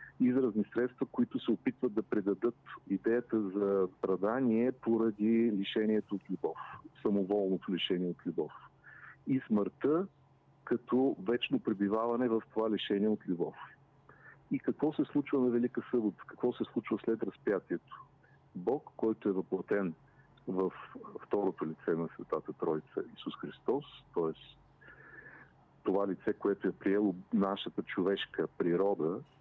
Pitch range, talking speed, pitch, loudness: 100-120 Hz, 125 wpm, 110 Hz, -34 LUFS